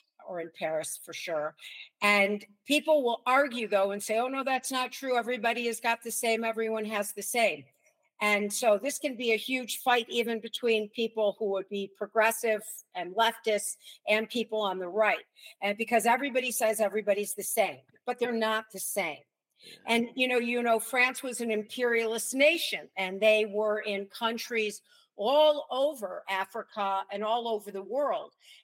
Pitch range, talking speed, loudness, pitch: 205-245 Hz, 175 wpm, -29 LUFS, 225 Hz